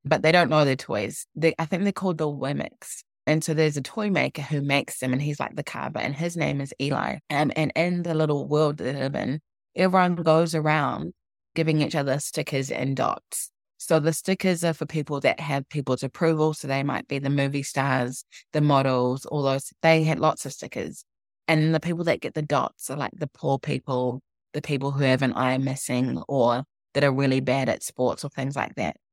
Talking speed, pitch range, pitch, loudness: 220 wpm, 135-160 Hz, 145 Hz, -25 LUFS